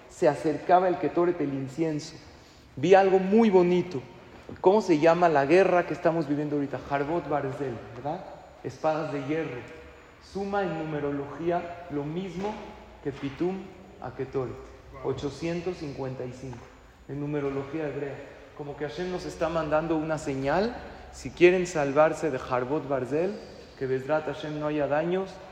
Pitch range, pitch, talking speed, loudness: 140-175 Hz, 155 Hz, 135 wpm, -27 LUFS